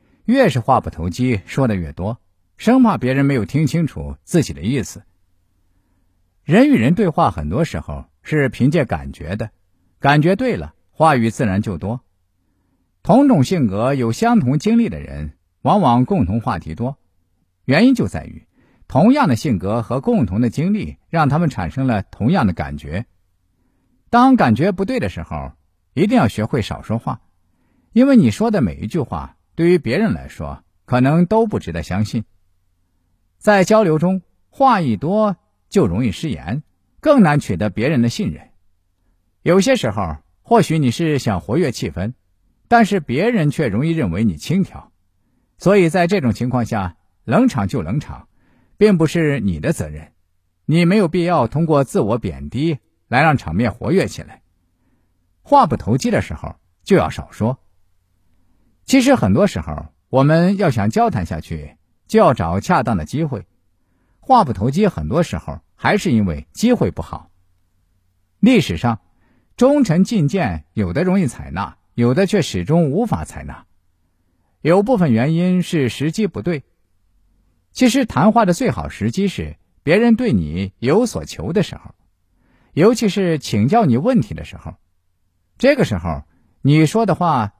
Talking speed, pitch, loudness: 230 characters per minute, 110 Hz, -17 LUFS